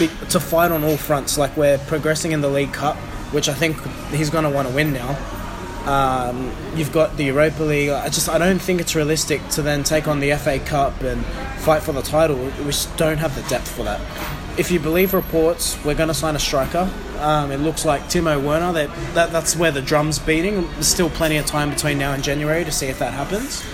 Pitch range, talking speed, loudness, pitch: 145-160 Hz, 235 wpm, -20 LUFS, 150 Hz